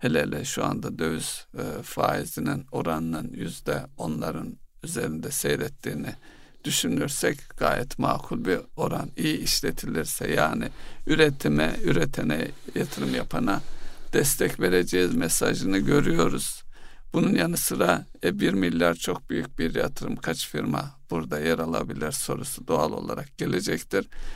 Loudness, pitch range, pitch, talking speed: -26 LUFS, 75-90 Hz, 80 Hz, 110 wpm